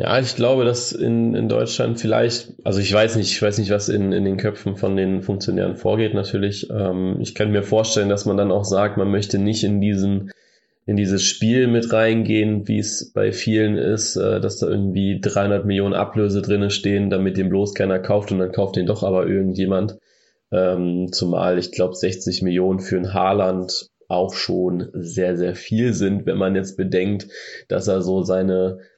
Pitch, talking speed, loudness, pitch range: 100 Hz, 195 wpm, -20 LUFS, 95-105 Hz